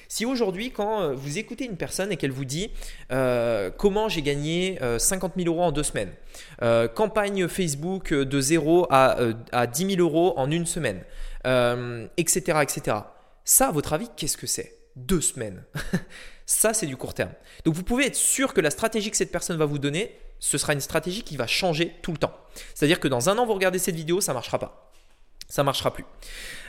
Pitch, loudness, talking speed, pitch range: 165 Hz, -24 LUFS, 210 wpm, 135-190 Hz